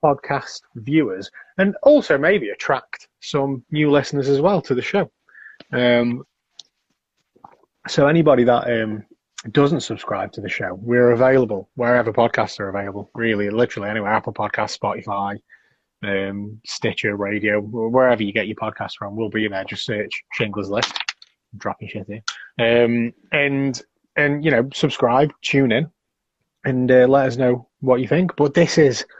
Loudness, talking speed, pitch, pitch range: -19 LUFS, 155 wpm, 120 Hz, 110-140 Hz